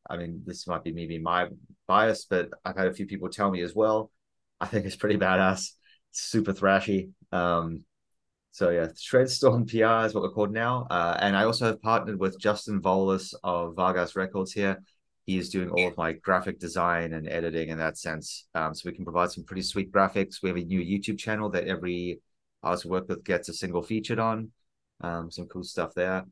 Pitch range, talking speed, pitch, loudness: 90-105 Hz, 210 wpm, 95 Hz, -28 LUFS